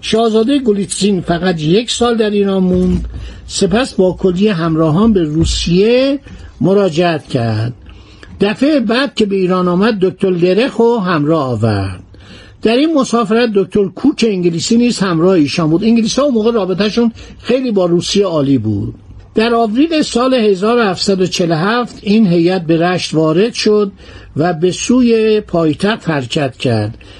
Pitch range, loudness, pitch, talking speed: 165-225 Hz, -13 LUFS, 195 Hz, 135 wpm